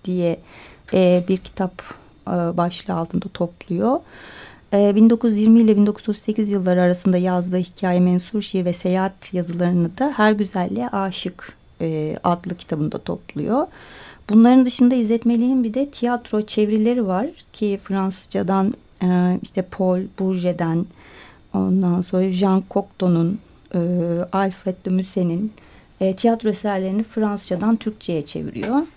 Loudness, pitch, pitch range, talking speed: -20 LUFS, 190 Hz, 180-215 Hz, 105 wpm